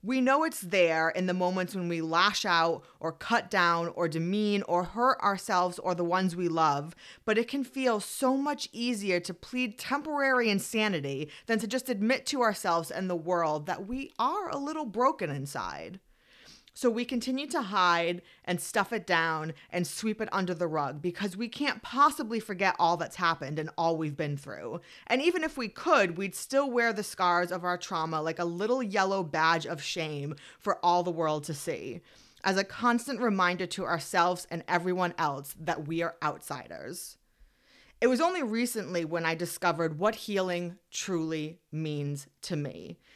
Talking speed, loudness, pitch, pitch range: 180 wpm, -30 LUFS, 180 Hz, 170-230 Hz